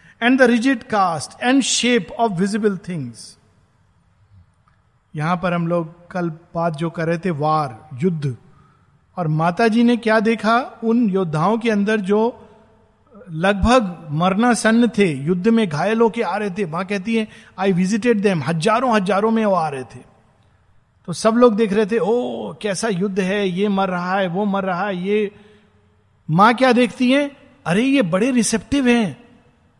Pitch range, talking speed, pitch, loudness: 165-230 Hz, 170 wpm, 200 Hz, -18 LUFS